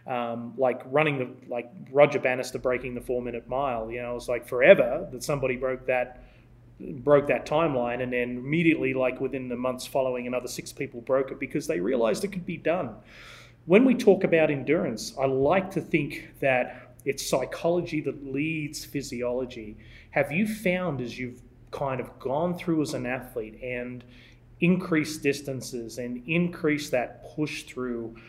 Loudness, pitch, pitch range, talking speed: -27 LUFS, 130 Hz, 125-155 Hz, 170 wpm